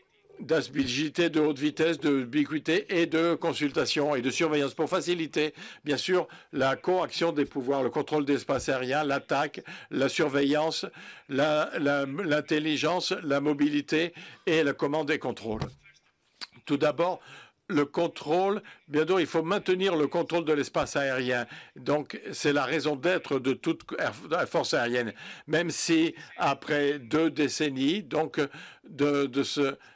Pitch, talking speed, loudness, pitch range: 150 Hz, 140 wpm, -28 LUFS, 145-170 Hz